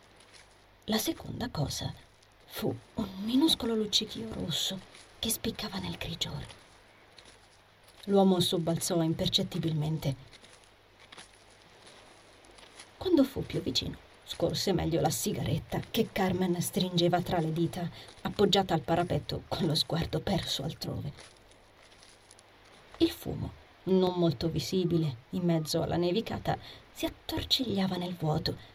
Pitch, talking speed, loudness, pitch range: 170 Hz, 105 wpm, -31 LUFS, 120-190 Hz